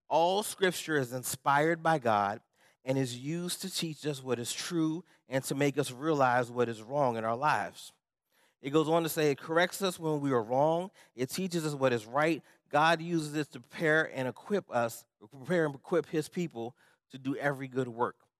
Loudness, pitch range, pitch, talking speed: -31 LUFS, 130-165 Hz, 150 Hz, 200 wpm